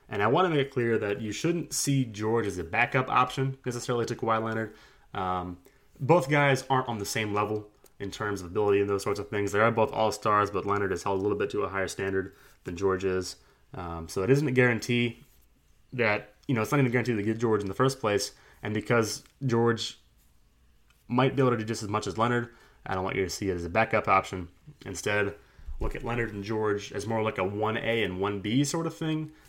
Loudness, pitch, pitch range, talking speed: -28 LUFS, 110 Hz, 100-130 Hz, 240 wpm